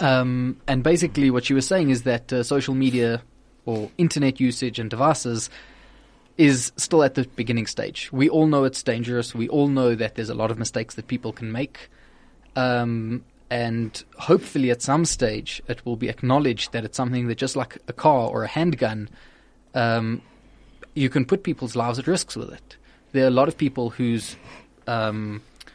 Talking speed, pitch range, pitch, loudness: 185 wpm, 115-135 Hz, 125 Hz, -23 LUFS